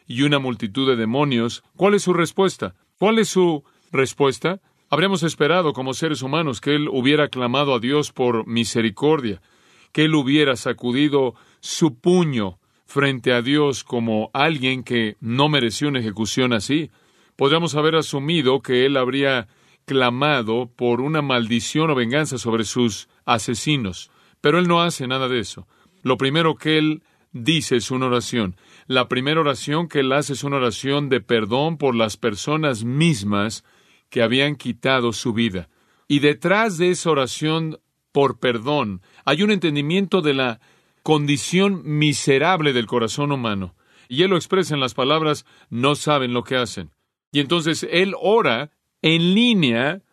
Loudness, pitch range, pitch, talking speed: -20 LUFS, 120-155 Hz, 140 Hz, 155 wpm